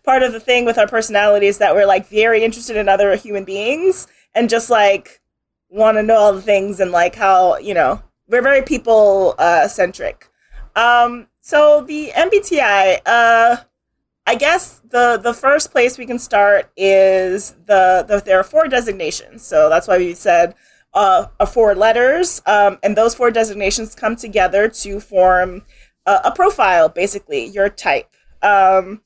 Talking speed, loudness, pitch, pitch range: 170 wpm, -14 LUFS, 220 Hz, 200-245 Hz